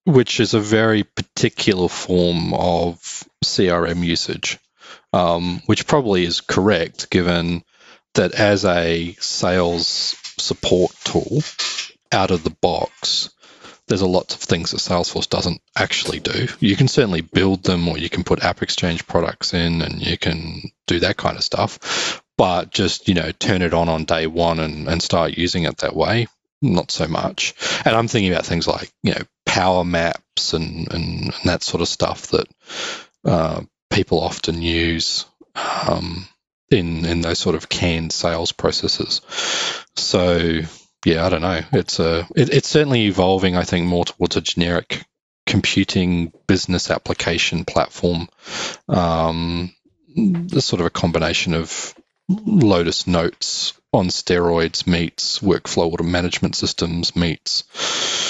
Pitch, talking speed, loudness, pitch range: 85 Hz, 150 wpm, -19 LUFS, 85-95 Hz